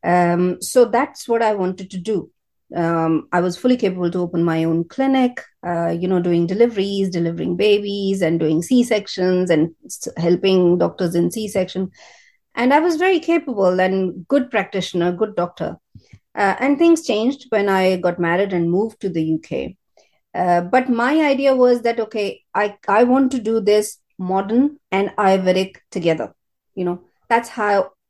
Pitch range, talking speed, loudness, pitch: 175-235 Hz, 165 wpm, -18 LUFS, 190 Hz